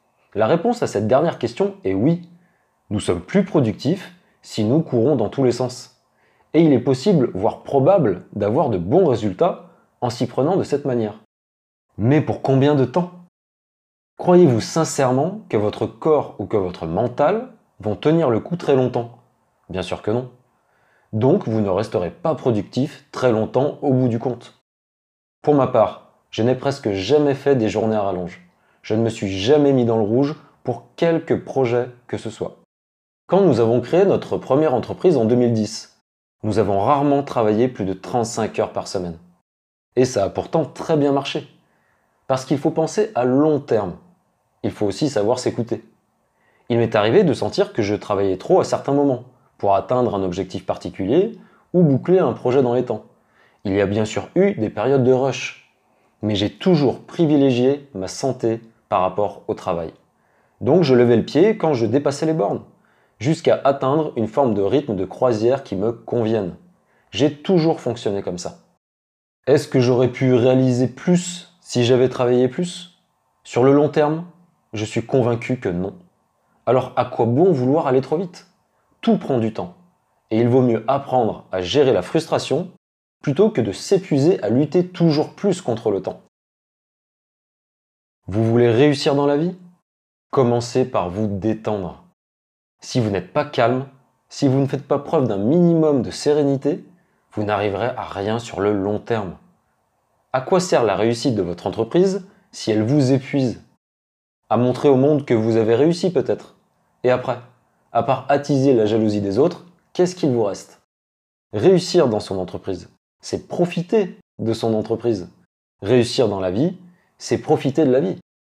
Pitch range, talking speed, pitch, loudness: 110-155 Hz, 175 wpm, 130 Hz, -19 LUFS